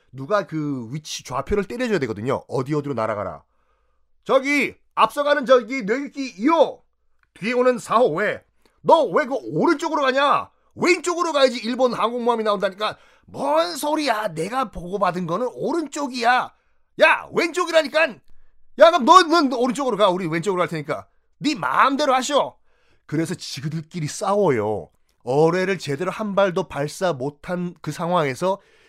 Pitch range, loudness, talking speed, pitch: 175-290 Hz, -21 LUFS, 320 characters per minute, 230 Hz